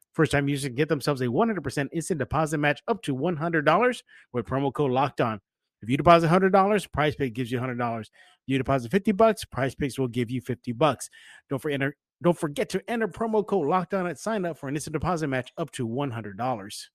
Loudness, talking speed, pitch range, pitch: -26 LUFS, 210 wpm, 130-180 Hz, 150 Hz